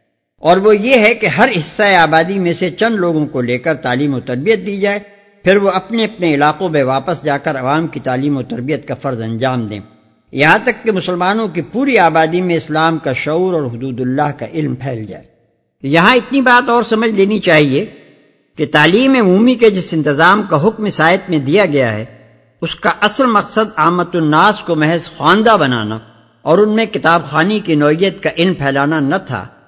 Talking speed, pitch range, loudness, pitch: 200 wpm, 145-205 Hz, -13 LUFS, 165 Hz